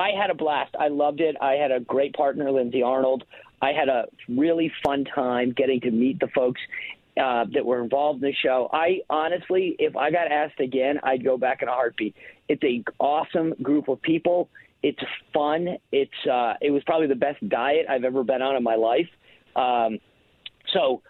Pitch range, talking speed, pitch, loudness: 130-155 Hz, 200 wpm, 140 Hz, -24 LUFS